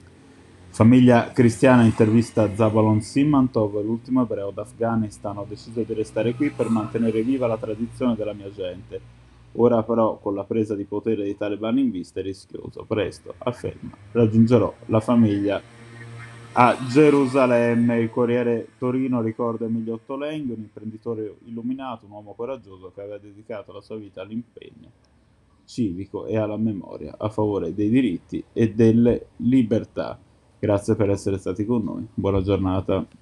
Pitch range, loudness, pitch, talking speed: 105-120 Hz, -22 LUFS, 115 Hz, 145 wpm